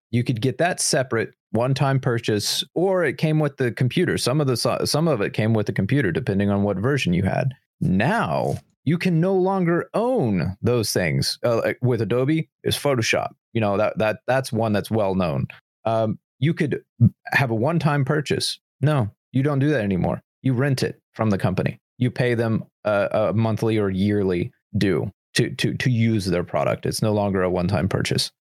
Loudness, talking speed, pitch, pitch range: -22 LUFS, 190 wpm, 125 Hz, 110-150 Hz